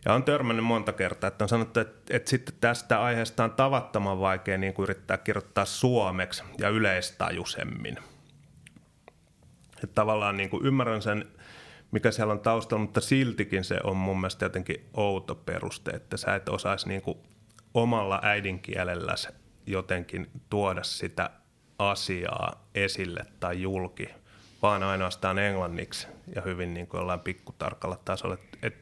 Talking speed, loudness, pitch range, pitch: 135 wpm, -29 LUFS, 95-115 Hz, 100 Hz